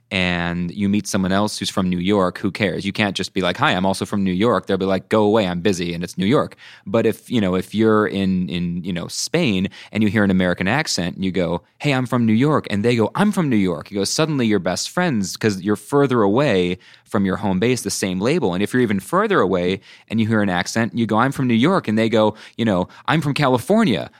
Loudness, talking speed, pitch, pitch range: -19 LUFS, 270 wpm, 100 Hz, 95-115 Hz